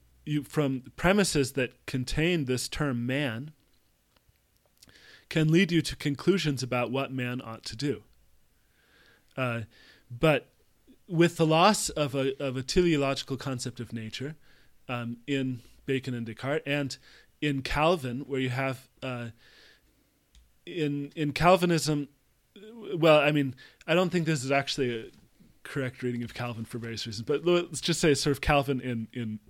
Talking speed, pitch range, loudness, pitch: 150 wpm, 125-155 Hz, -28 LUFS, 135 Hz